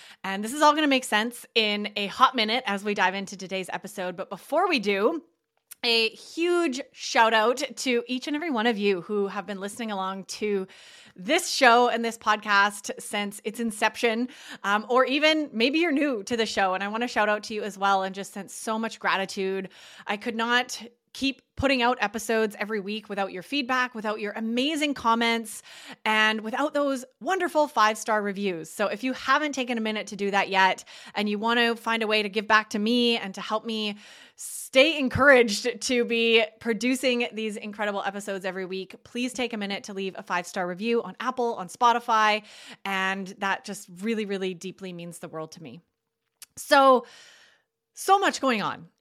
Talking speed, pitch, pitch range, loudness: 200 wpm, 220 Hz, 200-250 Hz, -25 LUFS